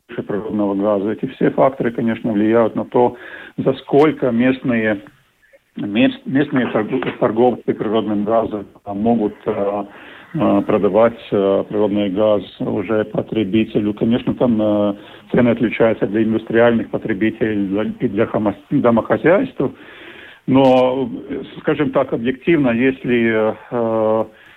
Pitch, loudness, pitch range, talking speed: 110 Hz, -17 LUFS, 105-125 Hz, 100 wpm